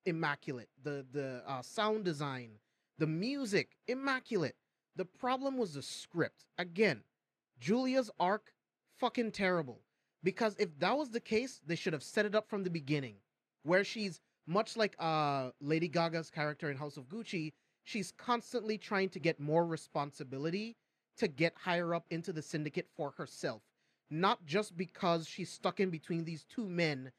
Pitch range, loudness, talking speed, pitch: 150-210 Hz, -37 LUFS, 160 wpm, 175 Hz